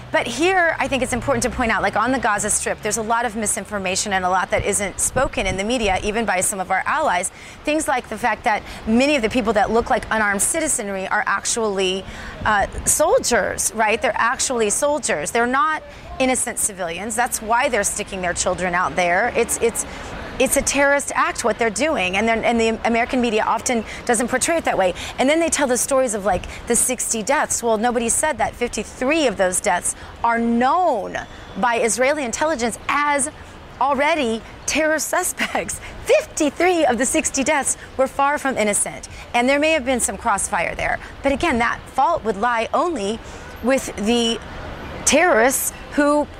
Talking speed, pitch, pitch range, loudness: 190 wpm, 240 Hz, 215-280 Hz, -19 LUFS